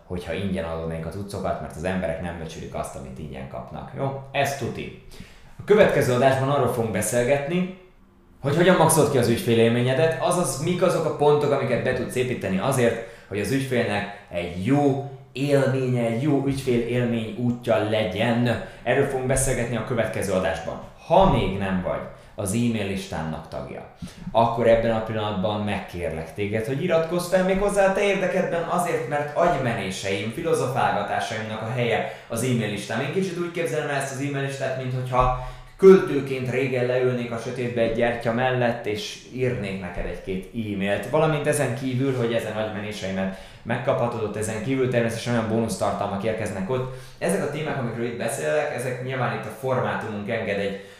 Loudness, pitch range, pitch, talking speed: -24 LUFS, 105-135 Hz, 120 Hz, 160 wpm